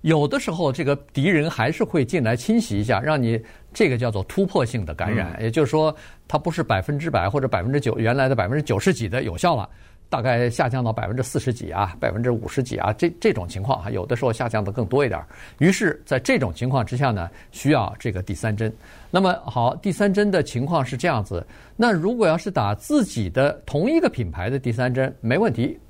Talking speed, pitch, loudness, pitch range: 340 characters per minute, 125 Hz, -22 LUFS, 110-155 Hz